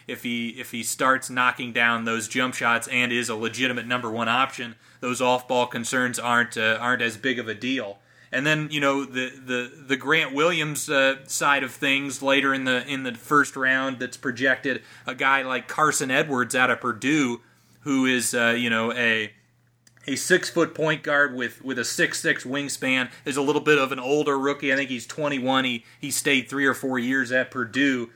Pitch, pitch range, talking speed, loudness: 130 Hz, 120-140 Hz, 210 wpm, -23 LUFS